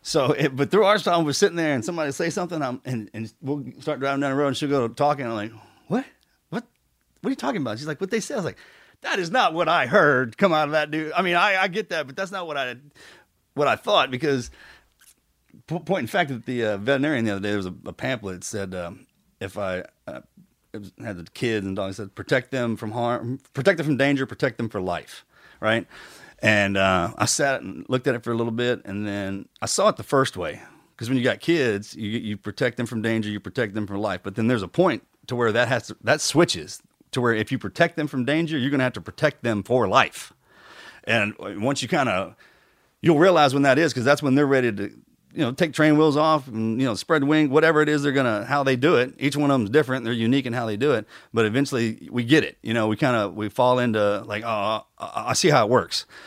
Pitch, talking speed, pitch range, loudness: 130 Hz, 265 wpm, 110-150 Hz, -23 LUFS